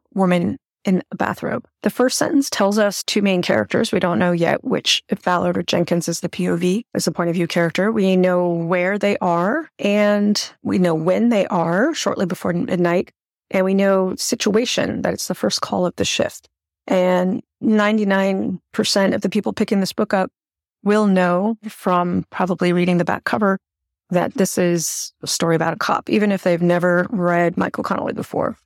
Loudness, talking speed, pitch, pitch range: -19 LUFS, 190 wpm, 190 Hz, 175-210 Hz